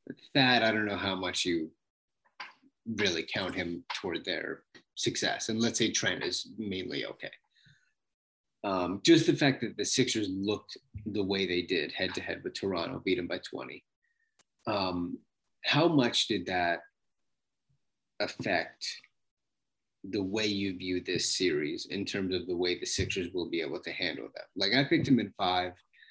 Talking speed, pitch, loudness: 170 wpm, 110 Hz, -30 LUFS